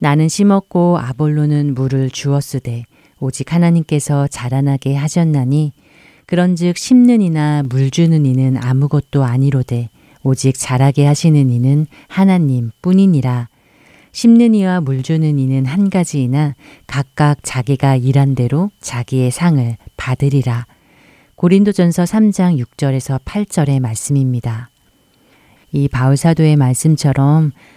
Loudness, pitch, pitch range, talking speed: -14 LUFS, 140 Hz, 130-160 Hz, 270 characters per minute